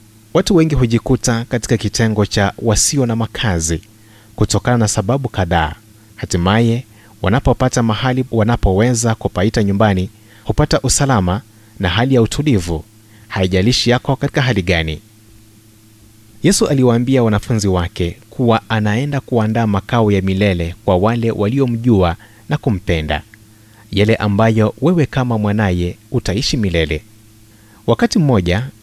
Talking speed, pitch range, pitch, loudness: 110 wpm, 105-125 Hz, 110 Hz, -16 LUFS